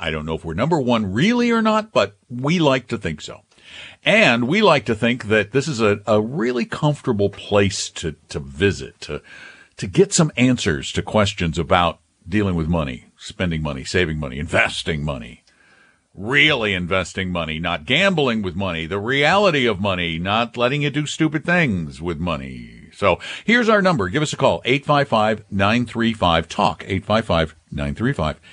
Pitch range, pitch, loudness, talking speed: 85-130 Hz, 105 Hz, -19 LUFS, 165 wpm